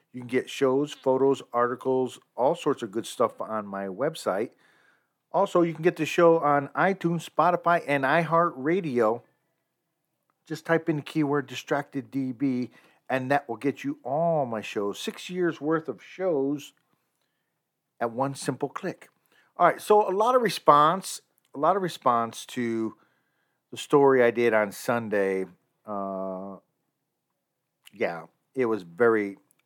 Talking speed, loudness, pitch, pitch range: 145 wpm, -26 LUFS, 140 Hz, 120-165 Hz